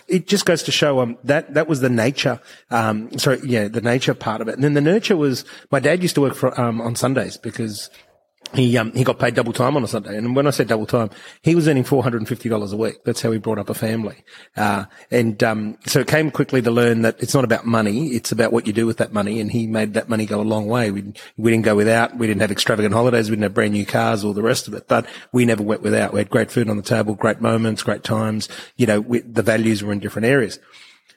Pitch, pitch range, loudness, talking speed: 115 Hz, 110-130 Hz, -19 LUFS, 275 wpm